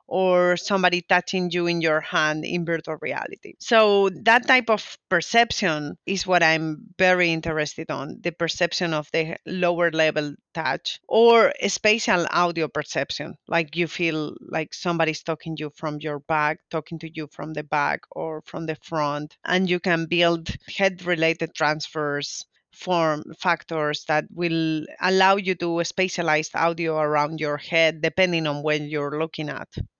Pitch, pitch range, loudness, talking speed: 165 Hz, 155-180 Hz, -23 LUFS, 150 wpm